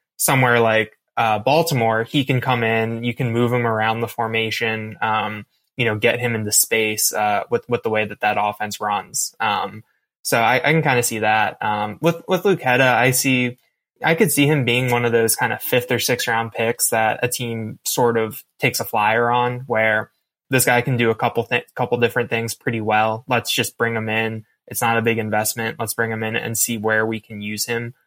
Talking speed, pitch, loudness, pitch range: 225 wpm, 115 Hz, -19 LUFS, 110-125 Hz